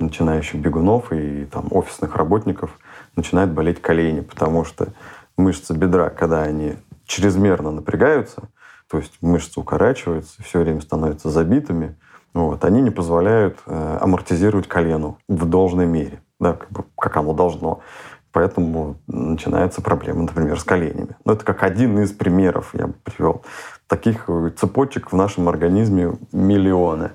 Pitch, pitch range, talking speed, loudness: 85 Hz, 80-95 Hz, 135 wpm, -19 LUFS